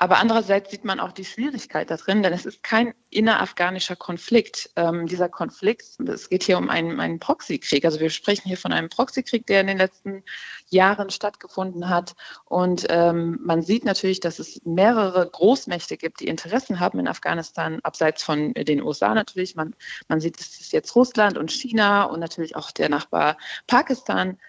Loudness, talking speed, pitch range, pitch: -22 LUFS, 180 wpm, 170-210 Hz, 185 Hz